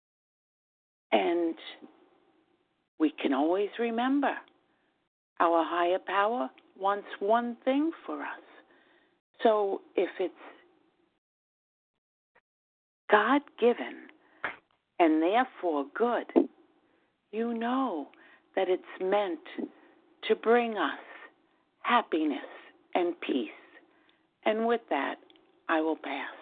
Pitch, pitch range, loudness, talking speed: 280 Hz, 220-345 Hz, -29 LUFS, 85 wpm